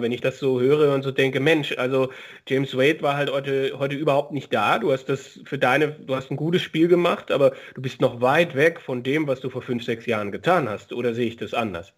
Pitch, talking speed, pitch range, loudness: 135 Hz, 255 wpm, 125-150 Hz, -22 LUFS